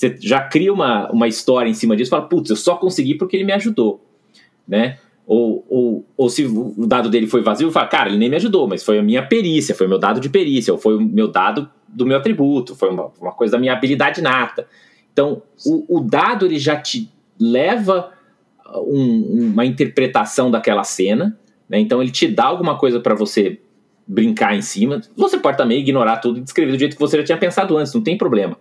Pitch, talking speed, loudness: 150 Hz, 220 wpm, -16 LUFS